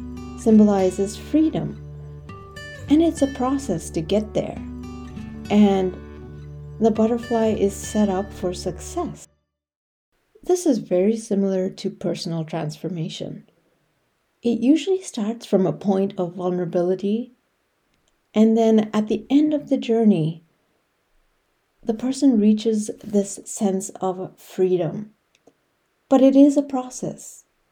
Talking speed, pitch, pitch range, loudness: 115 wpm, 200 Hz, 170-230 Hz, -21 LUFS